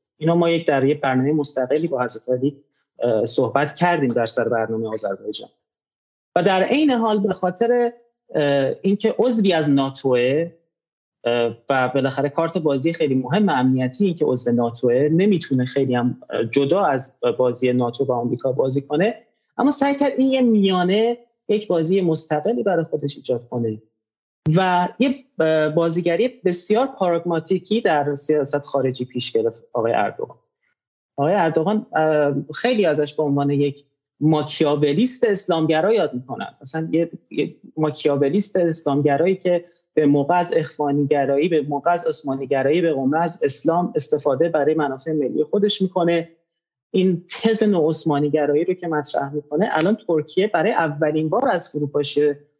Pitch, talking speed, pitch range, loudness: 155 Hz, 140 wpm, 140-190 Hz, -20 LUFS